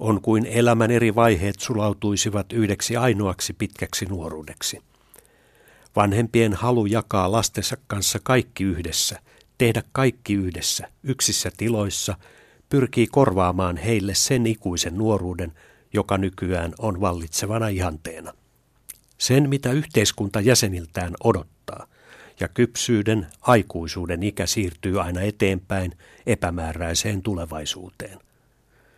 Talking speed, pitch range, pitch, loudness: 95 wpm, 90-115 Hz, 105 Hz, -22 LUFS